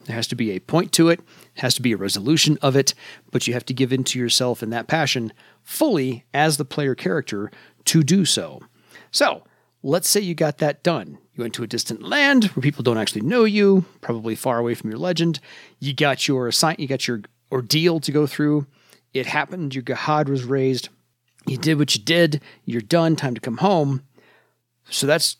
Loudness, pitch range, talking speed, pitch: -21 LUFS, 120-160 Hz, 210 wpm, 135 Hz